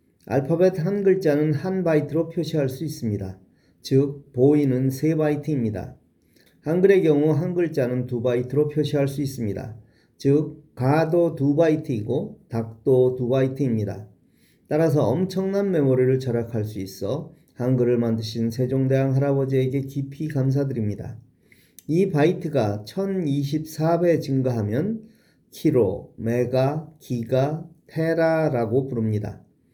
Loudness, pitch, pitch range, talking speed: -23 LUFS, 140 Hz, 125-155 Hz, 270 characters per minute